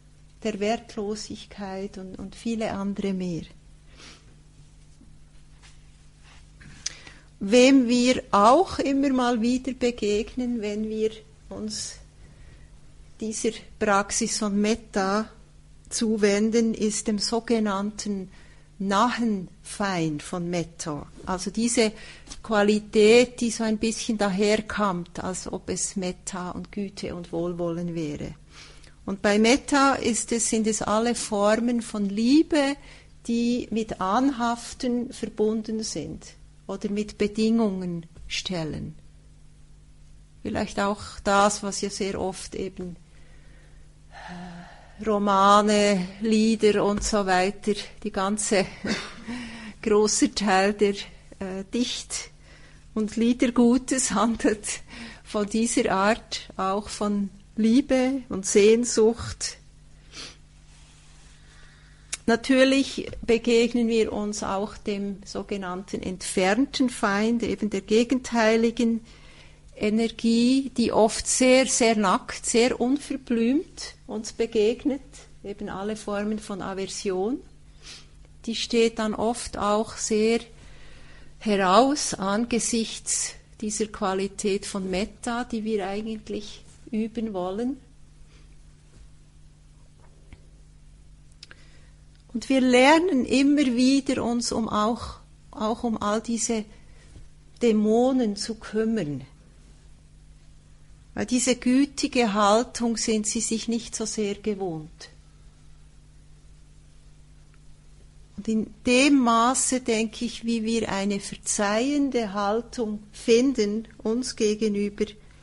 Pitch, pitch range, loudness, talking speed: 215 Hz, 190-230 Hz, -24 LUFS, 95 wpm